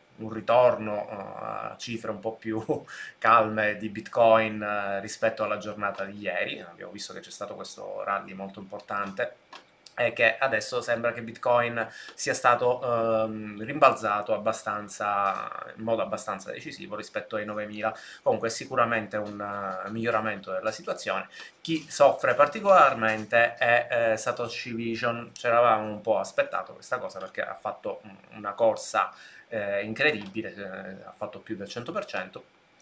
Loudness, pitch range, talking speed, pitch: -27 LUFS, 105-115 Hz, 135 wpm, 110 Hz